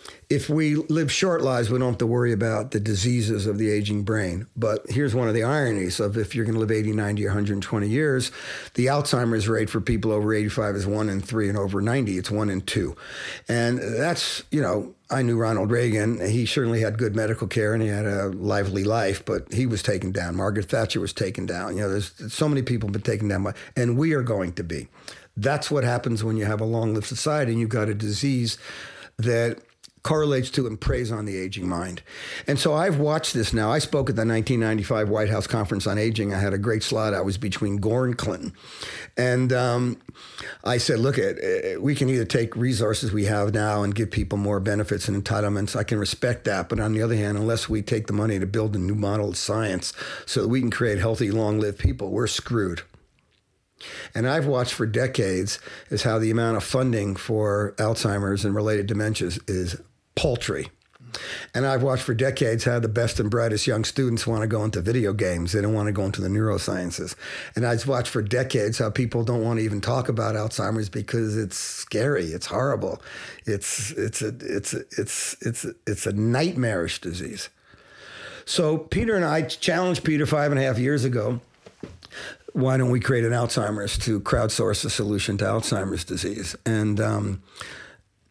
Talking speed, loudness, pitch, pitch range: 205 wpm, -24 LUFS, 110 Hz, 105-125 Hz